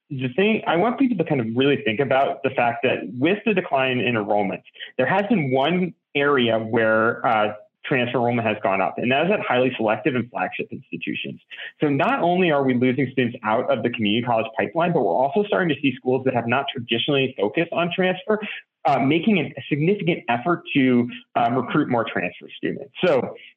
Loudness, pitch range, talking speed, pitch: -21 LUFS, 120-170 Hz, 200 wpm, 135 Hz